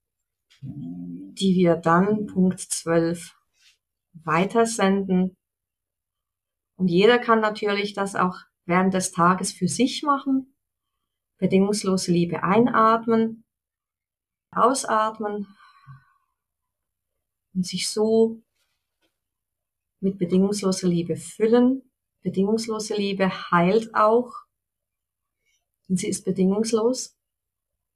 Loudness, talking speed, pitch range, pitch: -22 LUFS, 80 wpm, 175-220 Hz, 195 Hz